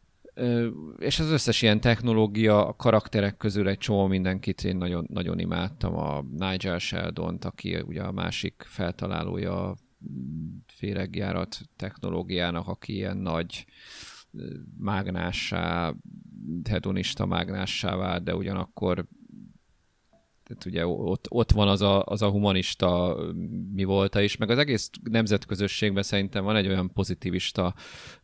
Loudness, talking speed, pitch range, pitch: -27 LUFS, 120 wpm, 90-105 Hz, 100 Hz